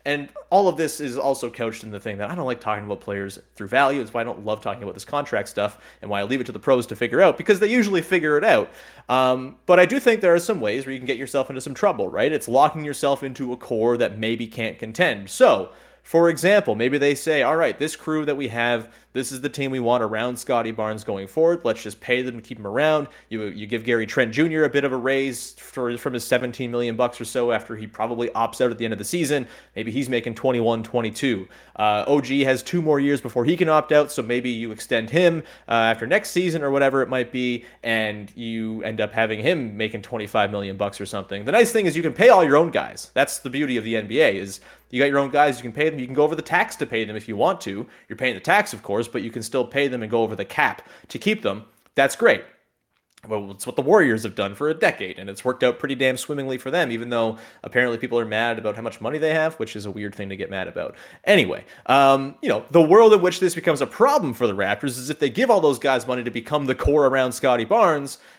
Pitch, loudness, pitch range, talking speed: 125 Hz, -21 LUFS, 115-145 Hz, 270 wpm